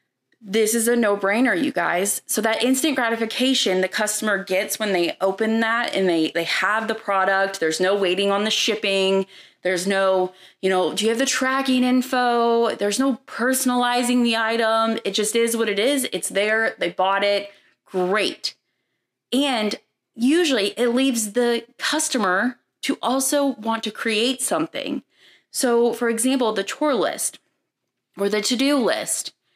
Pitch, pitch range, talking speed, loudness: 225 Hz, 195-250 Hz, 160 wpm, -21 LUFS